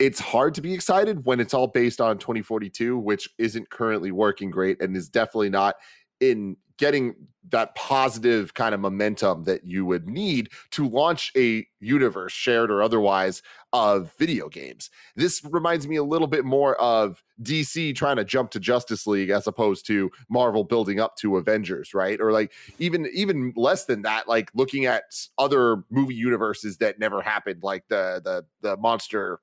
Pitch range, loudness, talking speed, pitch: 105-135 Hz, -24 LUFS, 175 wpm, 115 Hz